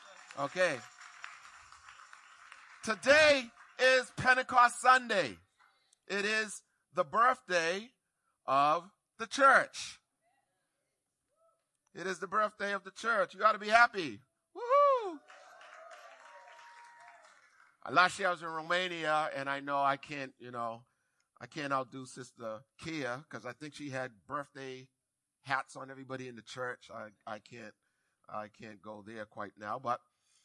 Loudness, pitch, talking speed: -31 LUFS, 165 Hz, 125 wpm